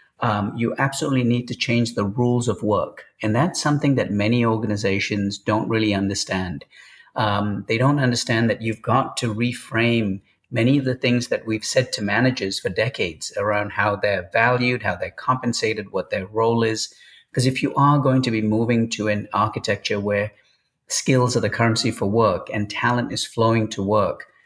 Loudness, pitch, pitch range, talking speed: -21 LUFS, 115 Hz, 105-125 Hz, 180 wpm